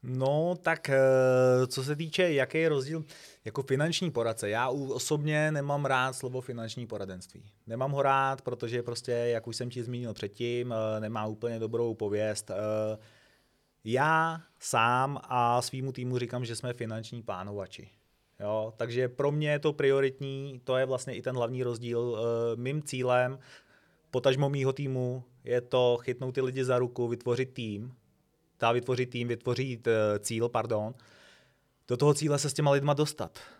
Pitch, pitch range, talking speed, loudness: 125 Hz, 115-135 Hz, 155 wpm, -30 LUFS